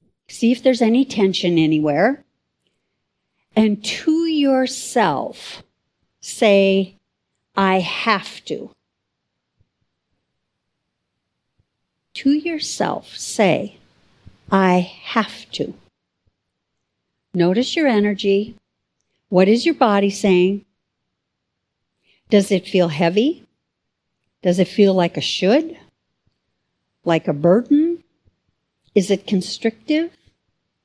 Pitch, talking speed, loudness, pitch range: 200 Hz, 85 wpm, -18 LUFS, 185-250 Hz